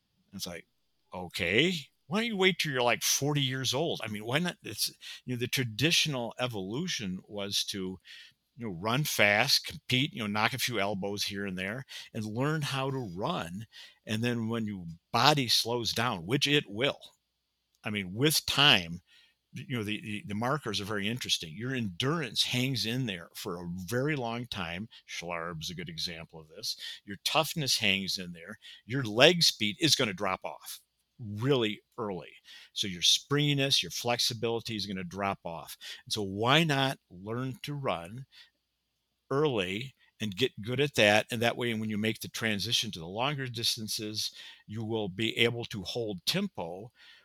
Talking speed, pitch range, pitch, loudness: 175 wpm, 100-135 Hz, 115 Hz, -30 LUFS